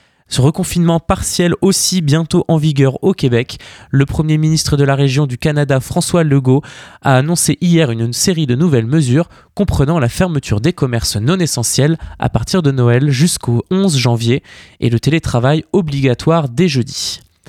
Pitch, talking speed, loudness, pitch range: 145 Hz, 160 wpm, -14 LUFS, 130-170 Hz